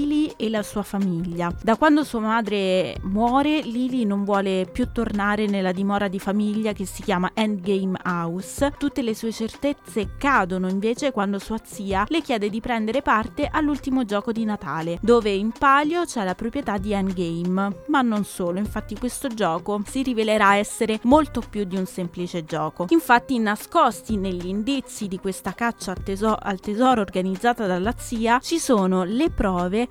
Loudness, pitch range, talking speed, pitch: -23 LUFS, 195-245 Hz, 160 wpm, 215 Hz